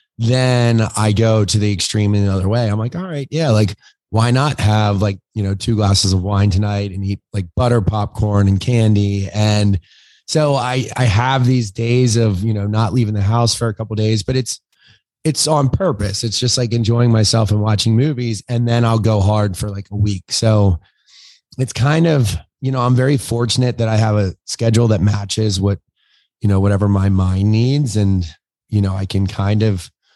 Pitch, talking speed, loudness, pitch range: 110 Hz, 205 wpm, -16 LUFS, 100-120 Hz